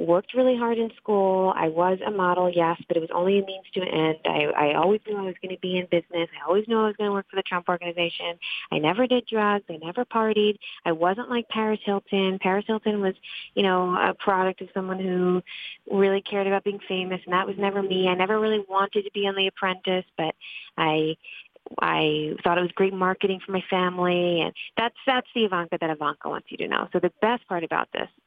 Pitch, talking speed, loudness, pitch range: 190 Hz, 230 wpm, -25 LUFS, 180-205 Hz